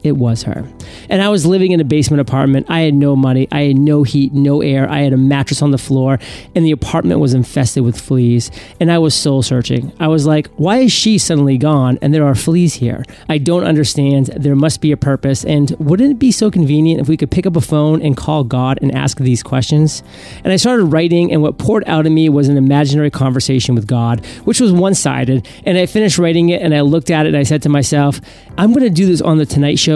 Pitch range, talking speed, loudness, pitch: 135-165 Hz, 250 wpm, -13 LUFS, 145 Hz